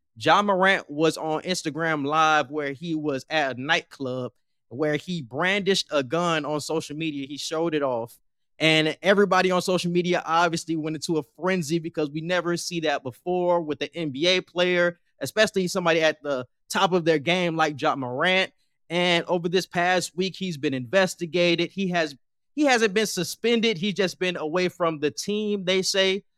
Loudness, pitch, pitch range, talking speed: -24 LUFS, 170 Hz, 155-185 Hz, 175 wpm